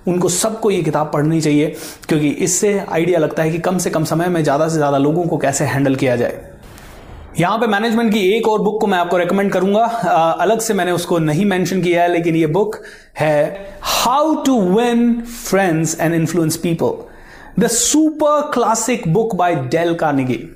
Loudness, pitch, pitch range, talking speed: -16 LUFS, 180 Hz, 160-220 Hz, 185 wpm